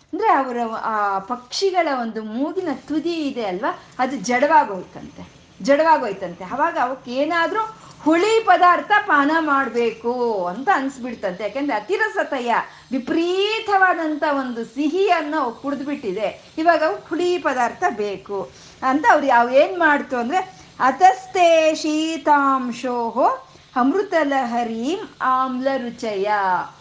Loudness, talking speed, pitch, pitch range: -20 LUFS, 95 wpm, 280 Hz, 240-330 Hz